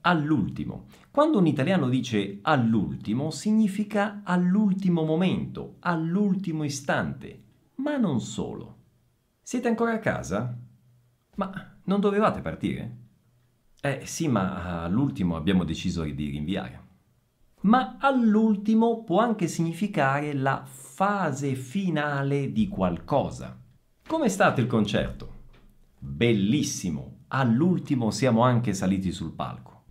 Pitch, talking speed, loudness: 155 Hz, 105 wpm, -26 LUFS